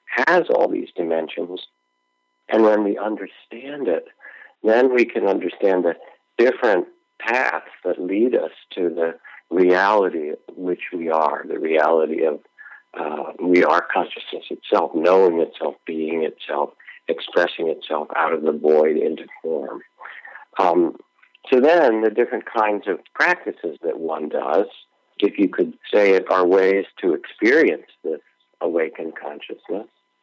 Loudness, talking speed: -20 LUFS, 135 wpm